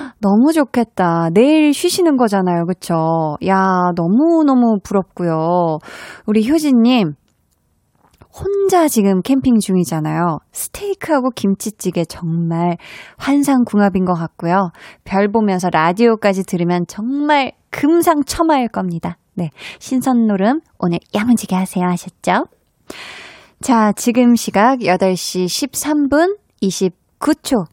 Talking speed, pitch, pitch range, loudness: 240 characters per minute, 200 Hz, 175-260 Hz, -16 LUFS